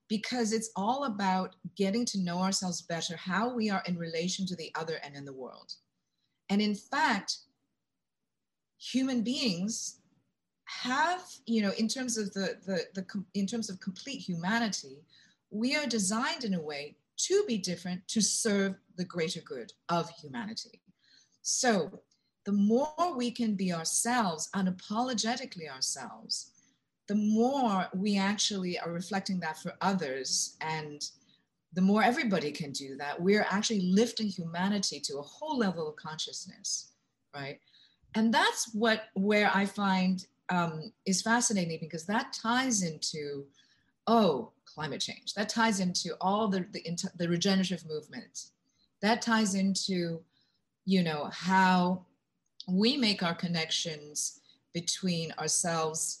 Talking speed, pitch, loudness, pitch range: 140 wpm, 195 Hz, -31 LUFS, 170-225 Hz